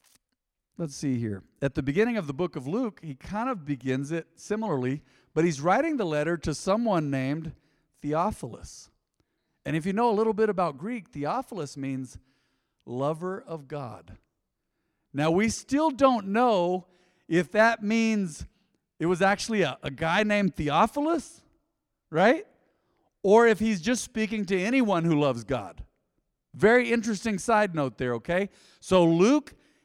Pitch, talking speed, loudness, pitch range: 180 Hz, 150 wpm, -26 LUFS, 150-220 Hz